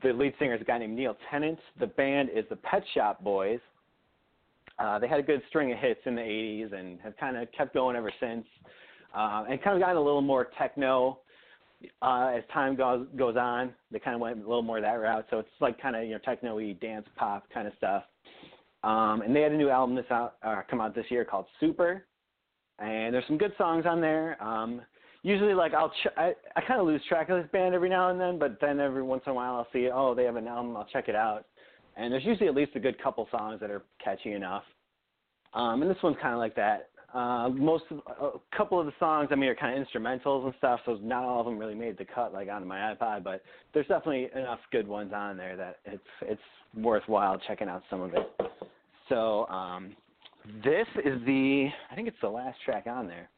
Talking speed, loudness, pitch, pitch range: 235 wpm, -30 LUFS, 130 Hz, 115-150 Hz